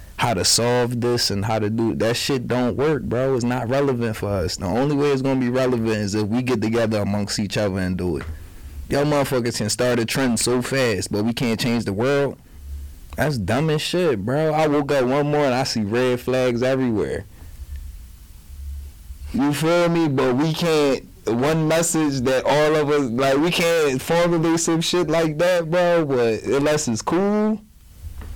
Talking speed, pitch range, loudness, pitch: 195 wpm, 105-145 Hz, -20 LUFS, 125 Hz